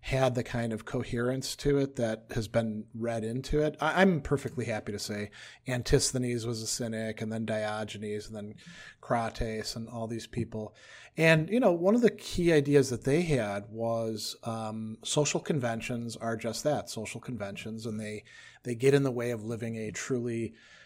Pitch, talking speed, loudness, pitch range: 115 Hz, 175 wpm, -31 LUFS, 110-135 Hz